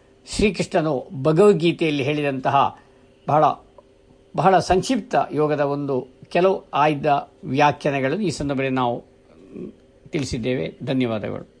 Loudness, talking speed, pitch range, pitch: -21 LUFS, 85 wpm, 135-175 Hz, 145 Hz